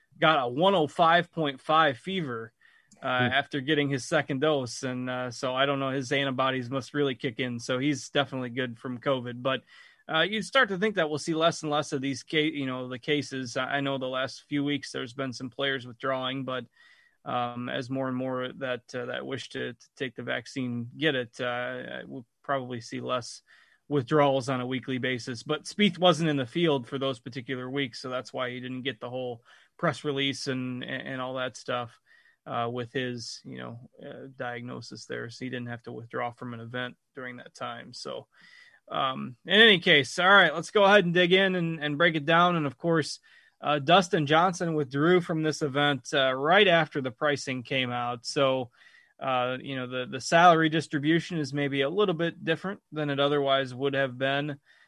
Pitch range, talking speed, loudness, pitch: 125-155 Hz, 200 wpm, -27 LUFS, 135 Hz